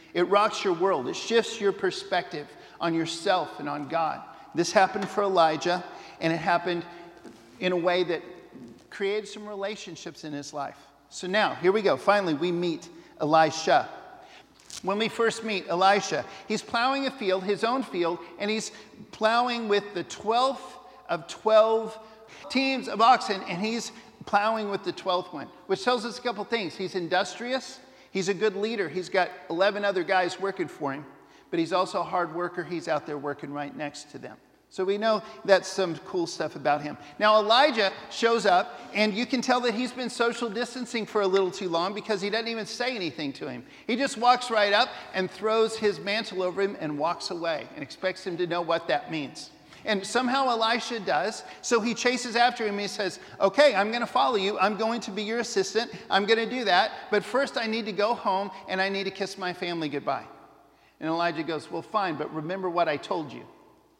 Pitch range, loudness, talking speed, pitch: 175-230 Hz, -27 LUFS, 200 wpm, 200 Hz